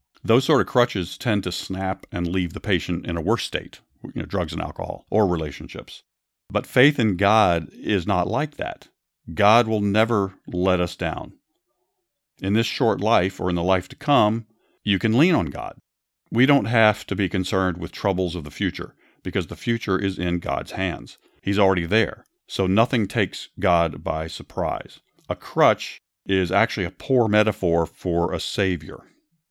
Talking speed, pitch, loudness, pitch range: 180 wpm, 95 Hz, -22 LUFS, 90-110 Hz